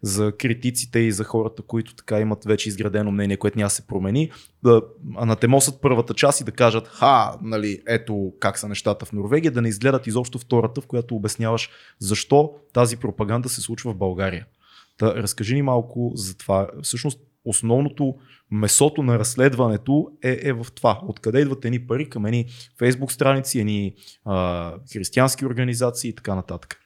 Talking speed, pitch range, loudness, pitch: 170 wpm, 105-130 Hz, -22 LUFS, 115 Hz